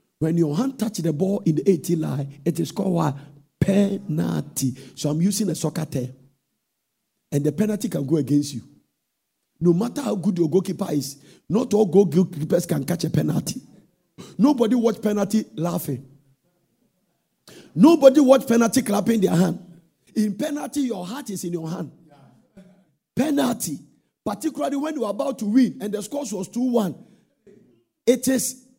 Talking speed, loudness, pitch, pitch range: 160 wpm, -22 LUFS, 190 Hz, 160-230 Hz